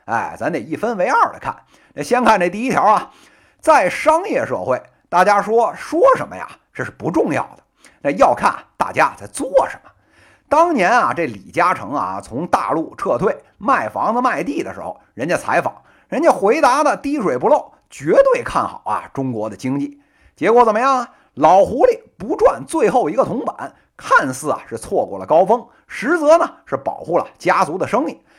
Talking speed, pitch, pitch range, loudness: 265 characters per minute, 290 Hz, 220-340 Hz, -17 LUFS